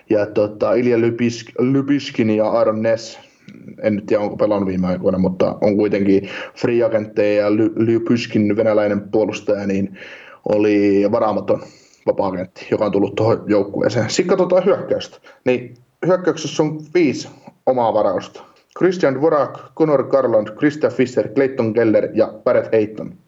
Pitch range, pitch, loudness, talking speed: 105-130 Hz, 115 Hz, -18 LUFS, 130 wpm